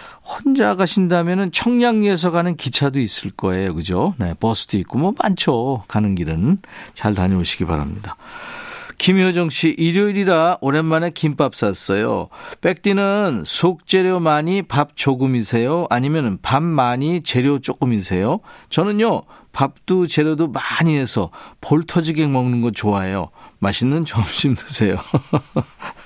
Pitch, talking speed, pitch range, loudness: 155 Hz, 280 characters per minute, 115-185 Hz, -18 LUFS